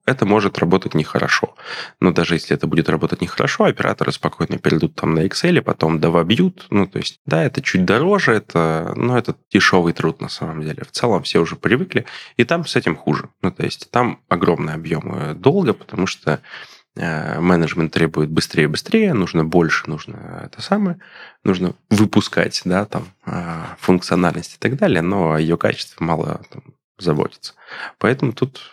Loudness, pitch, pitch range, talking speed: -18 LUFS, 90 Hz, 80-105 Hz, 175 wpm